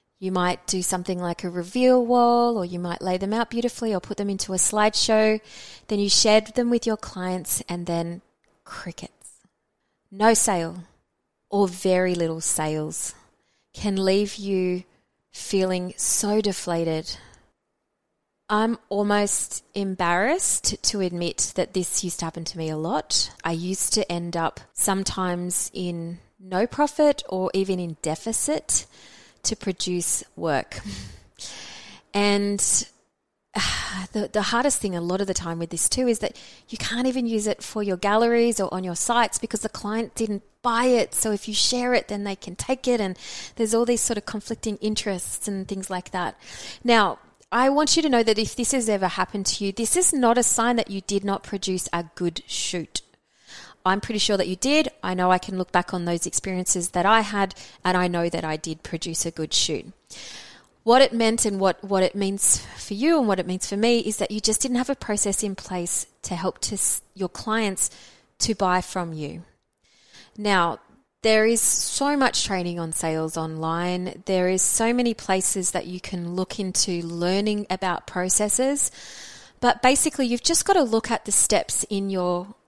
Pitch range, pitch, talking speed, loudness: 180-225 Hz, 195 Hz, 185 wpm, -23 LUFS